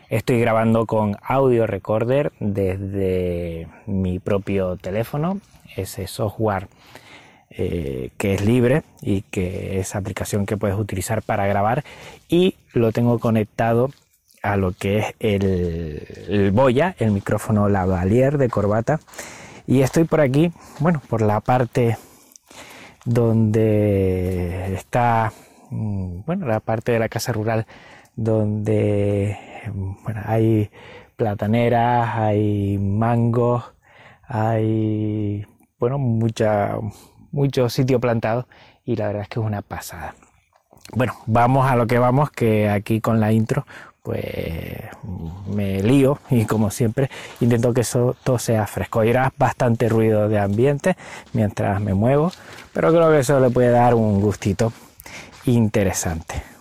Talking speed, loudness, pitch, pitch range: 125 wpm, -20 LUFS, 110 Hz, 100-120 Hz